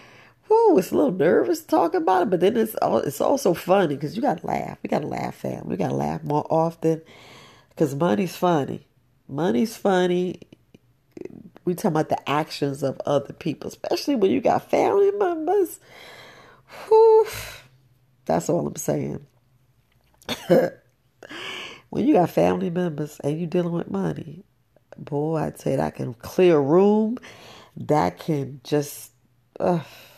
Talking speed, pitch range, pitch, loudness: 145 wpm, 140-200 Hz, 165 Hz, -22 LUFS